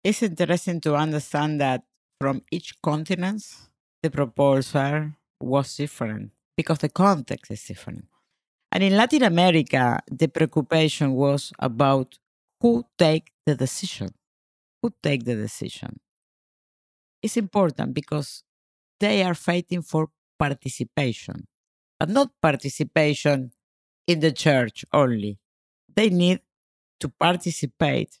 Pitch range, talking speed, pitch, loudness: 140-175 Hz, 110 wpm, 150 Hz, -23 LUFS